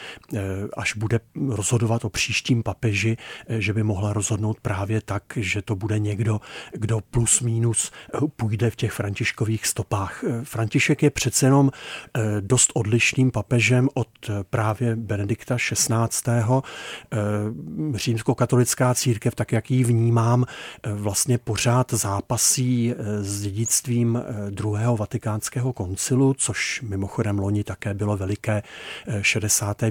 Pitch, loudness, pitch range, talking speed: 115 Hz, -23 LUFS, 105-125 Hz, 110 wpm